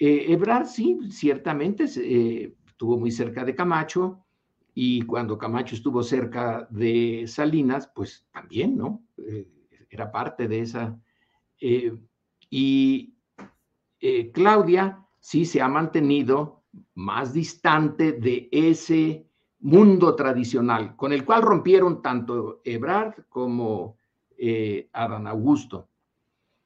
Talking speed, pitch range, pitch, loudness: 110 wpm, 115-180 Hz, 140 Hz, -23 LUFS